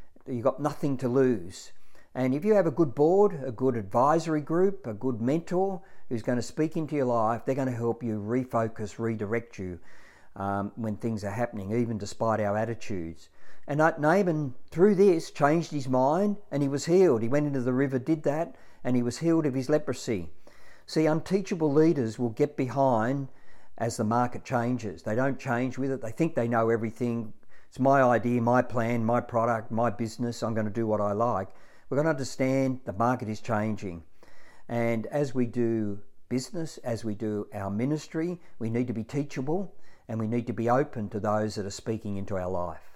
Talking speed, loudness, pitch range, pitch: 195 wpm, -28 LUFS, 110-145 Hz, 120 Hz